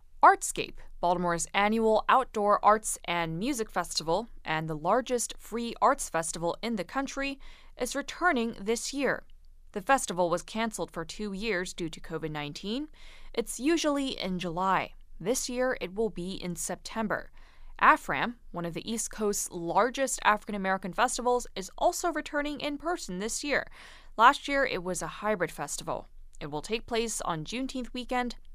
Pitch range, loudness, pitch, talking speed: 175-255 Hz, -29 LUFS, 215 Hz, 155 wpm